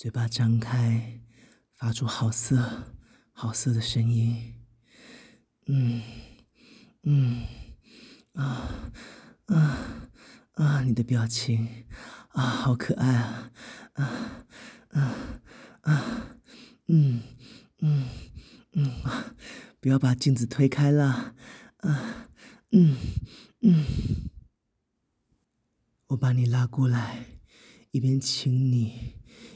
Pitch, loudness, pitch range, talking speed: 125 Hz, -26 LUFS, 115-140 Hz, 110 characters per minute